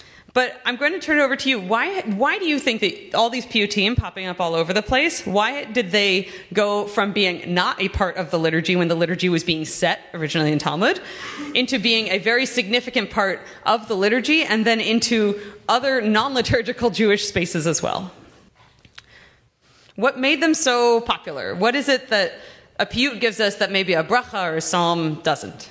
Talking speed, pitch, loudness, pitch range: 200 wpm, 215 Hz, -20 LUFS, 185-255 Hz